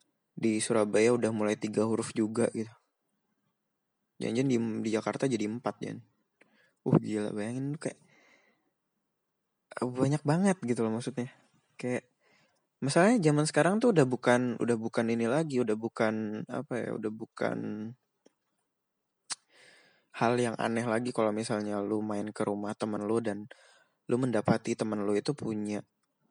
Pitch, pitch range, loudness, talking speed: 115 Hz, 105-125 Hz, -30 LUFS, 135 wpm